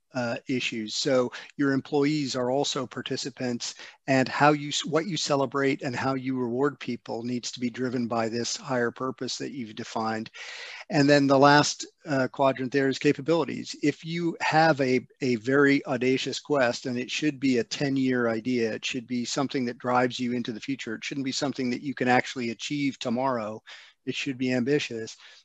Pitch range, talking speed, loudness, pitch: 125-140 Hz, 185 wpm, -26 LUFS, 130 Hz